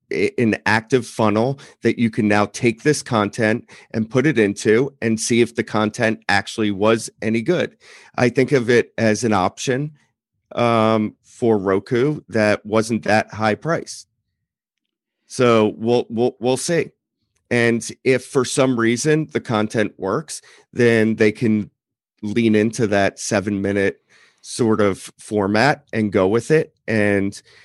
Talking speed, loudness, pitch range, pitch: 145 wpm, -19 LUFS, 105-120 Hz, 110 Hz